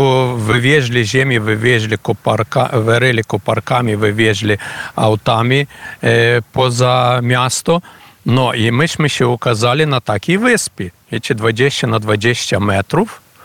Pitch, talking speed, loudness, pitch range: 120 Hz, 120 wpm, -14 LUFS, 110-130 Hz